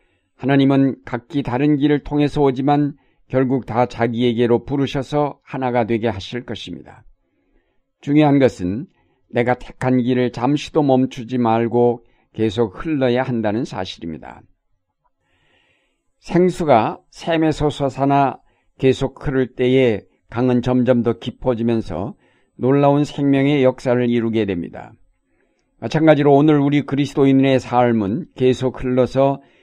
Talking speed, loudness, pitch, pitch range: 270 characters per minute, -18 LUFS, 130 Hz, 120-140 Hz